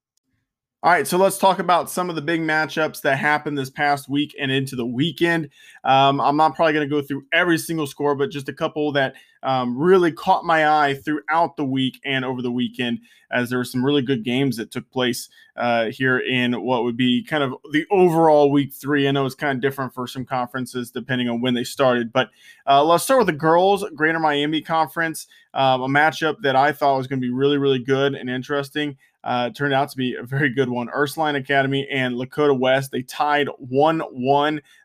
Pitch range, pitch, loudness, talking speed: 130-150 Hz, 140 Hz, -20 LUFS, 220 wpm